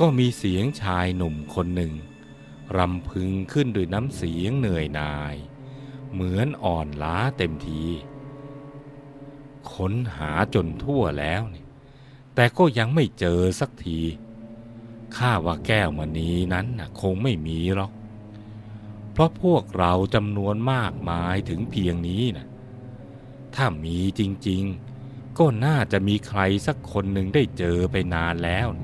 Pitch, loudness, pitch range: 105 Hz, -24 LUFS, 90-125 Hz